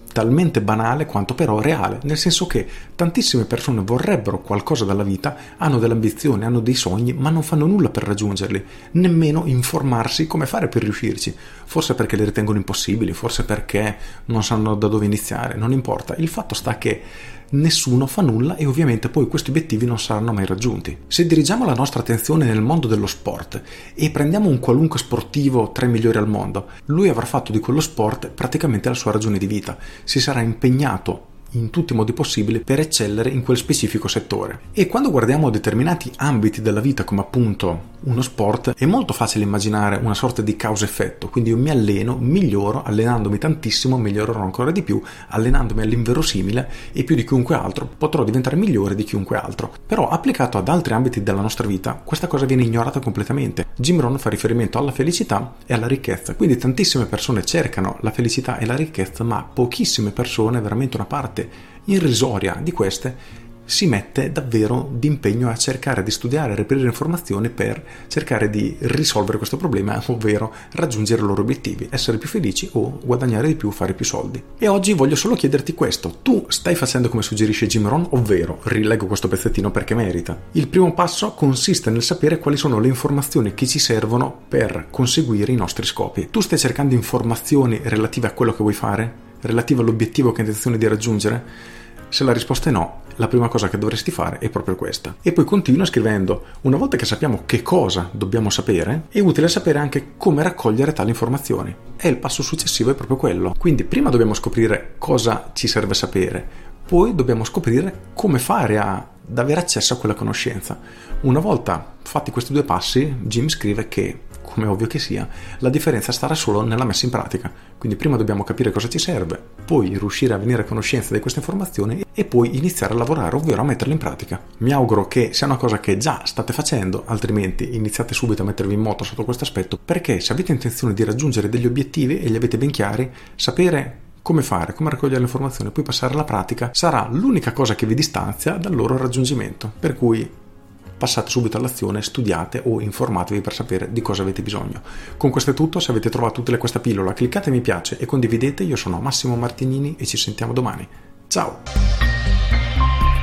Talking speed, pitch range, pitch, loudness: 185 wpm, 105-140 Hz, 120 Hz, -19 LUFS